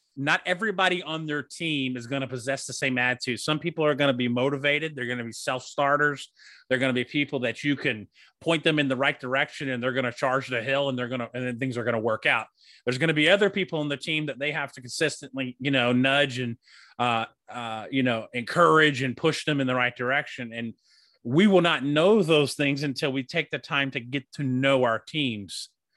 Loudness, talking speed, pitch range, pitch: -25 LUFS, 245 wpm, 125-150 Hz, 135 Hz